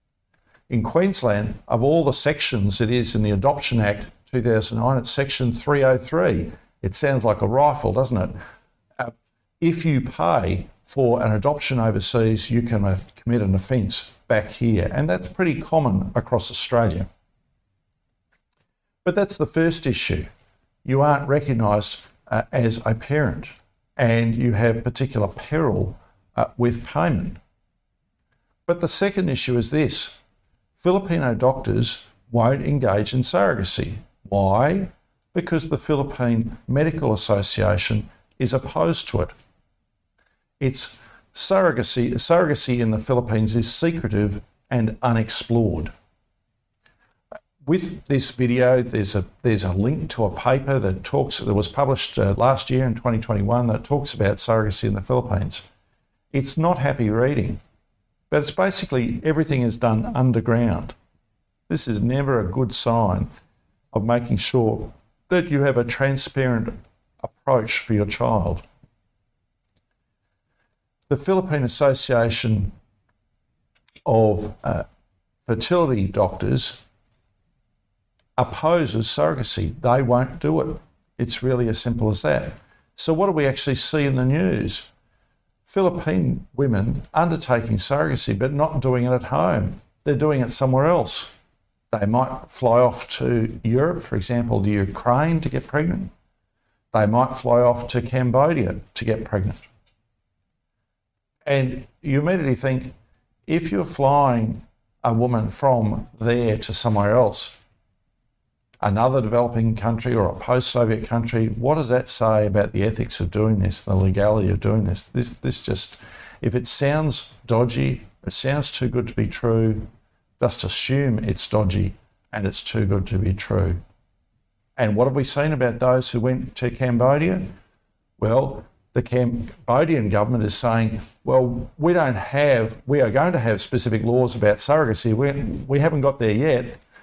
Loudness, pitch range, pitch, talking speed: -21 LUFS, 105-135 Hz, 120 Hz, 140 wpm